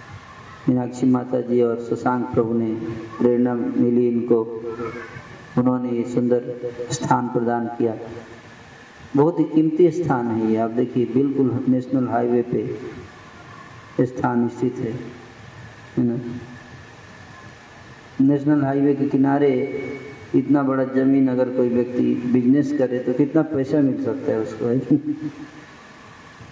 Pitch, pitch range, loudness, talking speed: 120 Hz, 115-130 Hz, -21 LUFS, 115 wpm